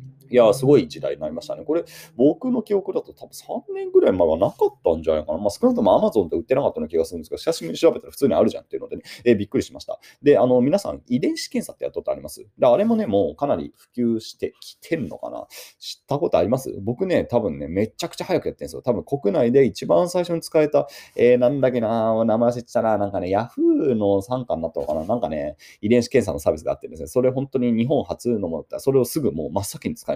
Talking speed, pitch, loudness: 545 characters per minute, 145 Hz, -21 LUFS